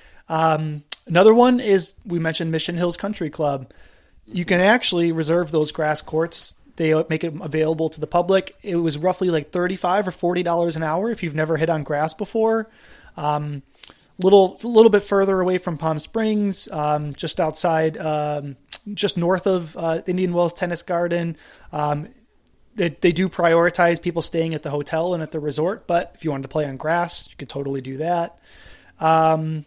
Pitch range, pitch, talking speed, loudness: 155-185 Hz, 170 Hz, 185 wpm, -21 LUFS